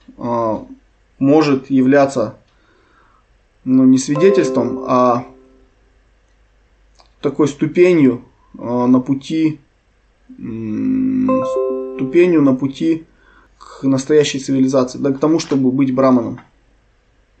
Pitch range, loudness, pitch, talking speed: 125-150 Hz, -15 LUFS, 135 Hz, 75 wpm